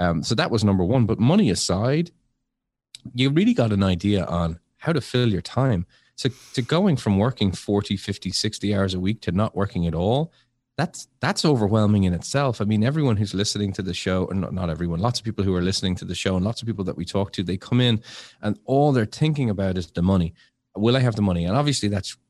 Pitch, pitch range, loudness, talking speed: 105 Hz, 95-125 Hz, -23 LUFS, 240 wpm